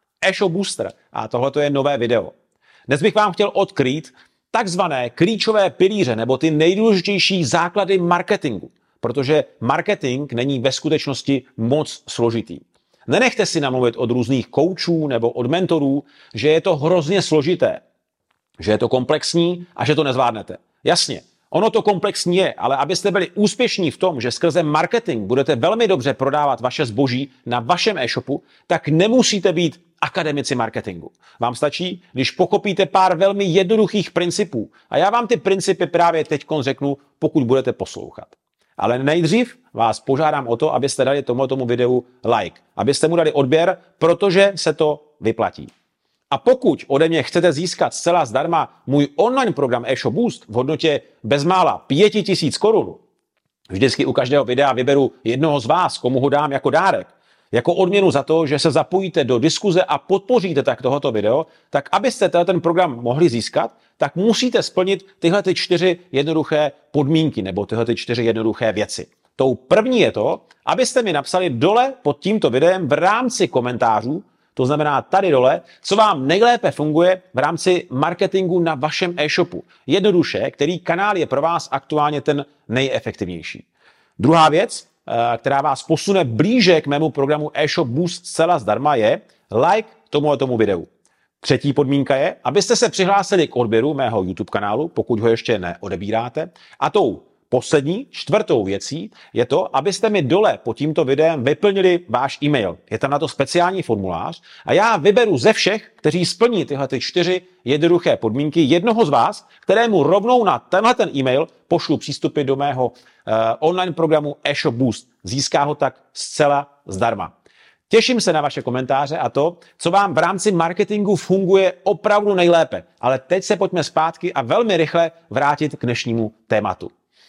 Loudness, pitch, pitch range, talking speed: -18 LUFS, 155 Hz, 135-185 Hz, 155 wpm